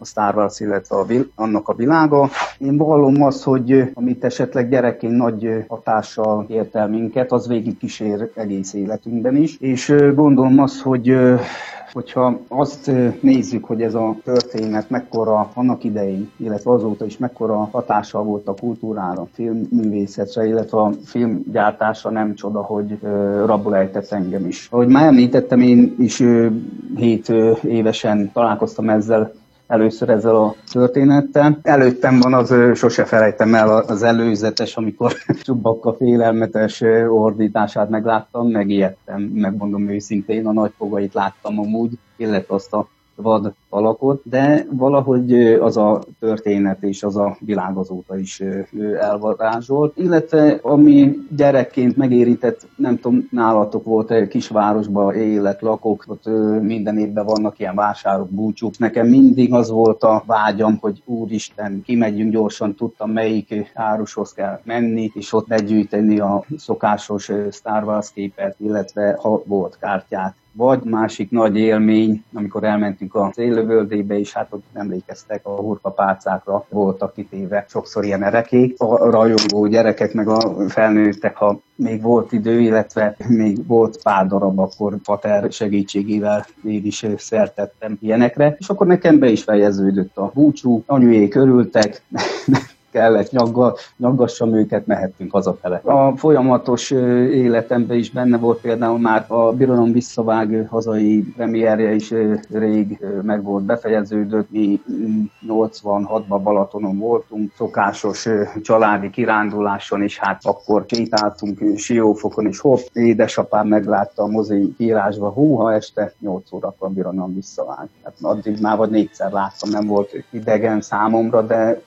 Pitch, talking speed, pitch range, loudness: 110 Hz, 135 wpm, 105-120 Hz, -17 LUFS